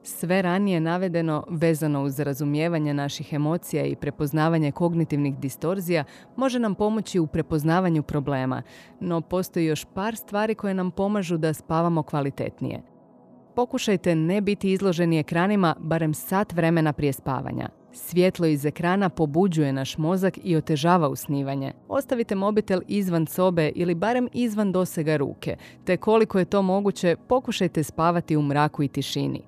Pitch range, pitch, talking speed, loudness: 150-190 Hz, 170 Hz, 140 wpm, -24 LUFS